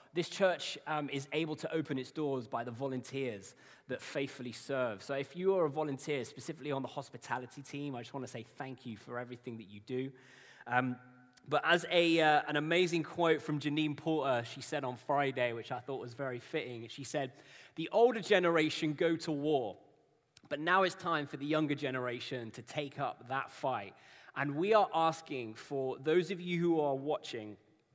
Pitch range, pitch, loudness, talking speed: 125-160 Hz, 140 Hz, -35 LUFS, 195 wpm